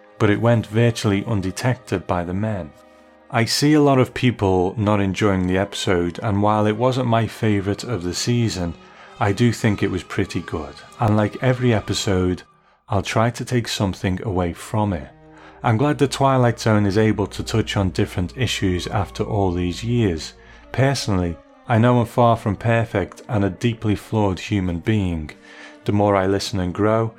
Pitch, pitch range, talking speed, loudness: 105 Hz, 95-115 Hz, 180 wpm, -20 LUFS